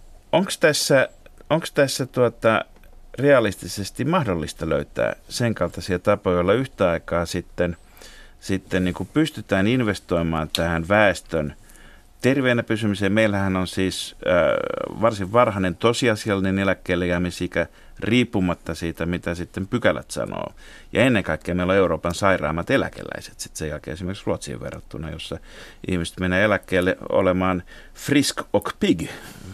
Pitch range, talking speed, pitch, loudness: 85-105 Hz, 125 wpm, 95 Hz, -22 LUFS